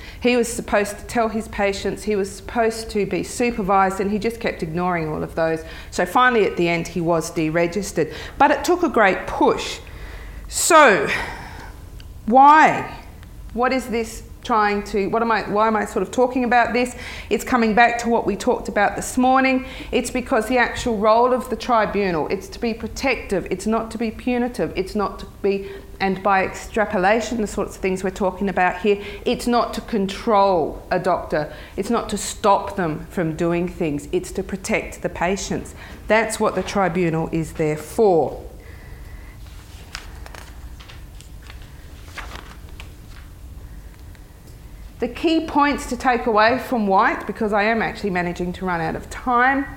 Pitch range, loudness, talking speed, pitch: 175-235 Hz, -20 LUFS, 170 wpm, 205 Hz